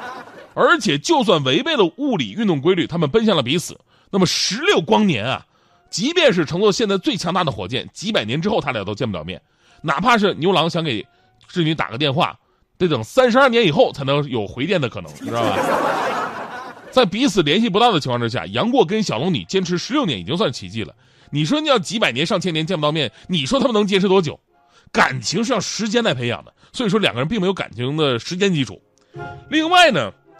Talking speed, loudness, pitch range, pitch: 325 characters per minute, -18 LUFS, 150-225 Hz, 185 Hz